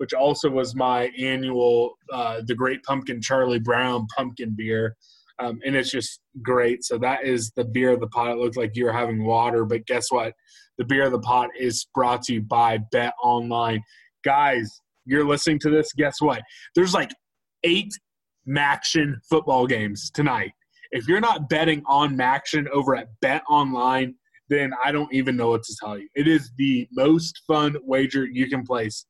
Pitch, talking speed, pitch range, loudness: 130 Hz, 185 wpm, 120-145 Hz, -23 LUFS